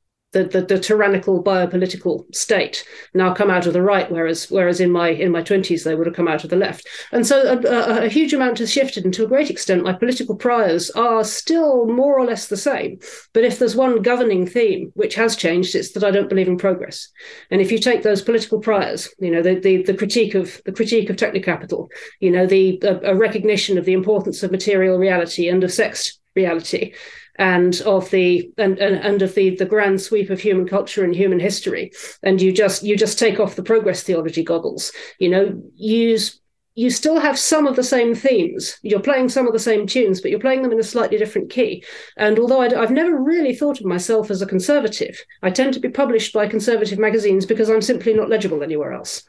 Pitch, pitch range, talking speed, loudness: 210 Hz, 185-240 Hz, 225 wpm, -18 LUFS